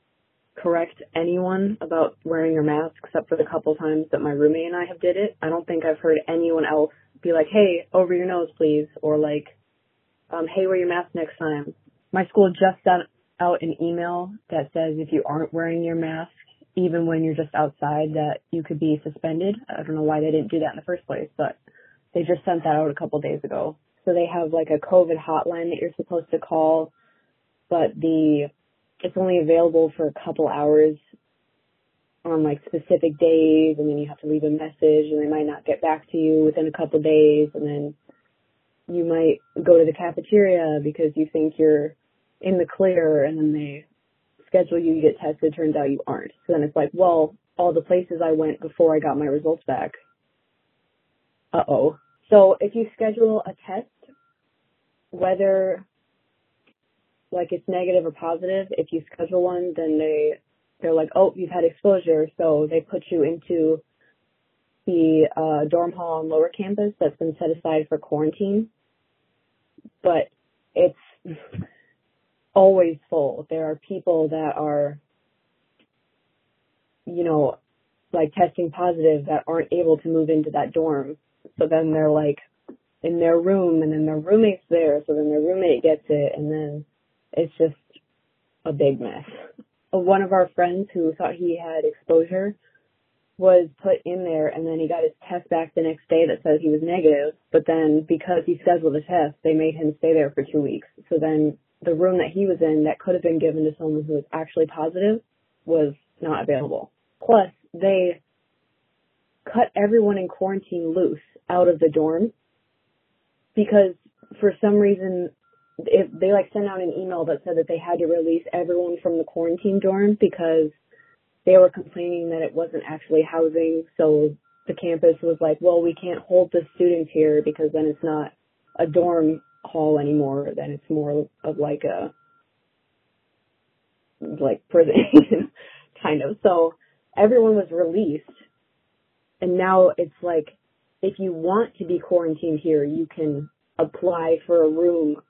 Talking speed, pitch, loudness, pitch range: 175 wpm, 165 Hz, -21 LUFS, 155-180 Hz